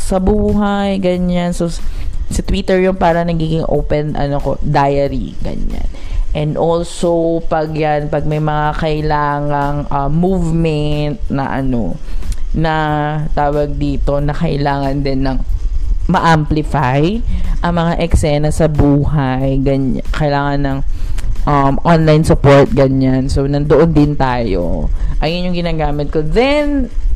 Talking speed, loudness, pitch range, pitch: 120 wpm, -15 LUFS, 140-165 Hz, 150 Hz